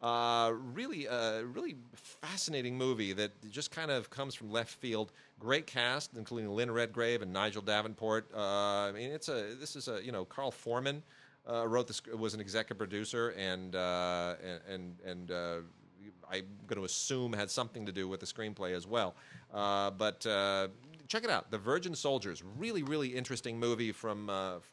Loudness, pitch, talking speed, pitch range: -37 LUFS, 110 Hz, 180 wpm, 100-125 Hz